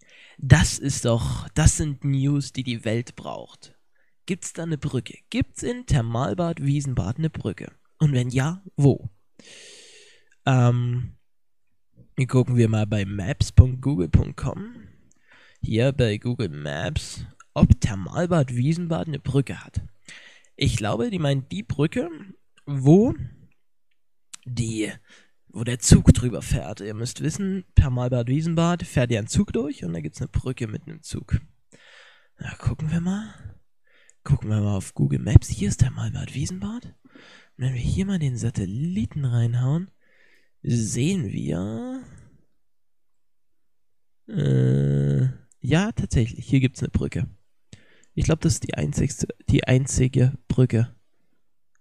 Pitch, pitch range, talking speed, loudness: 130 Hz, 115-155 Hz, 130 wpm, -23 LUFS